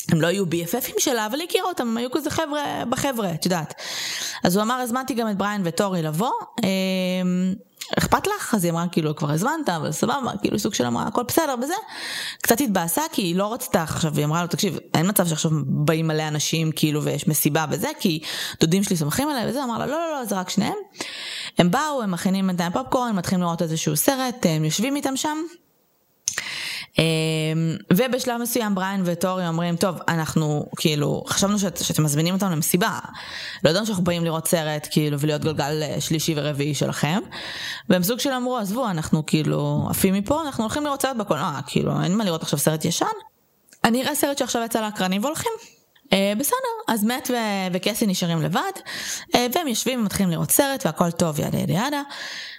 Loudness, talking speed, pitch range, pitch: -23 LUFS, 185 wpm, 165-250 Hz, 190 Hz